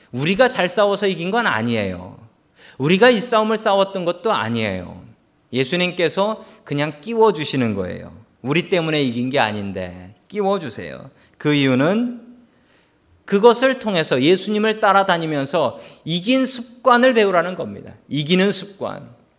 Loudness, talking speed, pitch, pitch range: -18 LUFS, 305 characters per minute, 180 Hz, 135-215 Hz